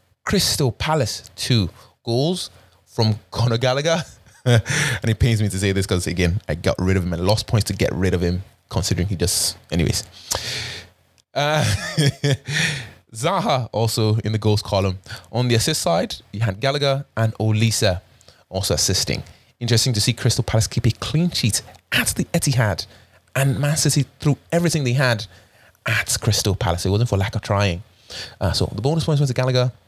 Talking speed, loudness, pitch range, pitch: 175 wpm, -21 LUFS, 95-130 Hz, 110 Hz